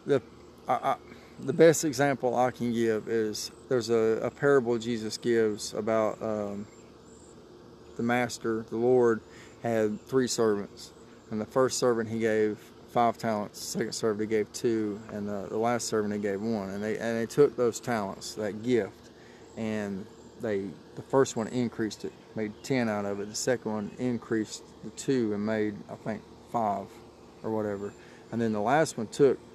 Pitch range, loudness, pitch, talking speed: 110-120 Hz, -29 LUFS, 115 Hz, 175 wpm